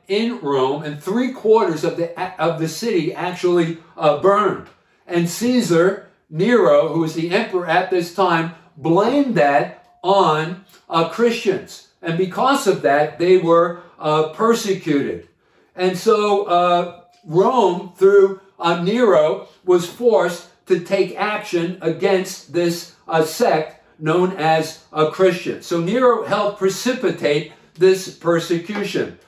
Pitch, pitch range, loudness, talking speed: 180 Hz, 165-195 Hz, -18 LUFS, 130 wpm